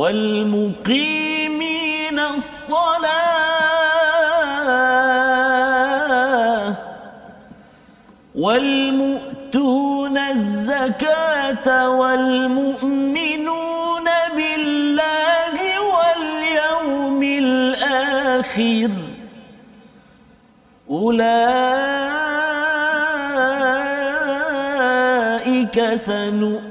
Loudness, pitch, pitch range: -18 LUFS, 275 Hz, 255-310 Hz